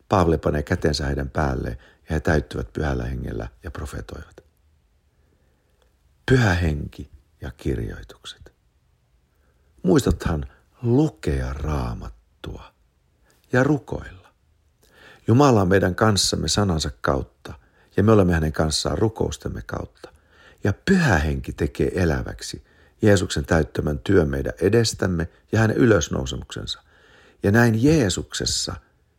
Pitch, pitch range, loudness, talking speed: 80 Hz, 75-100 Hz, -22 LUFS, 100 wpm